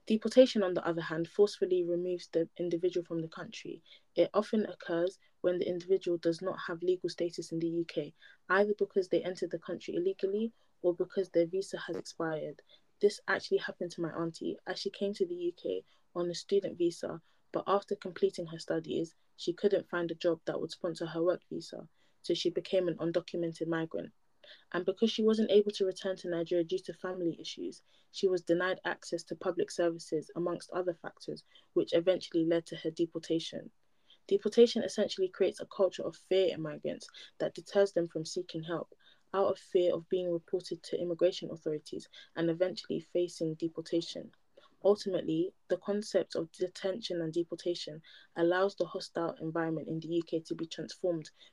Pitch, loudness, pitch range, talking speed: 180 Hz, -34 LUFS, 170-195 Hz, 175 wpm